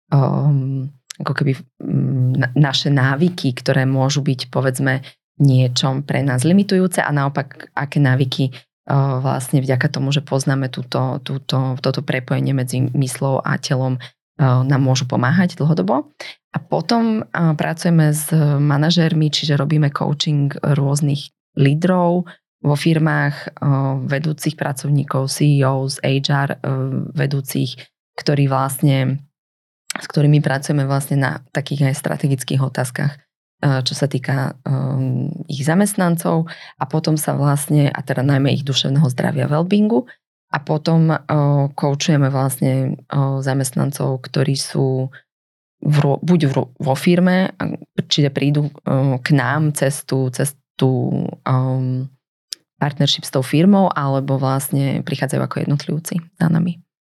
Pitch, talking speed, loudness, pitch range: 140 Hz, 110 wpm, -18 LUFS, 135-155 Hz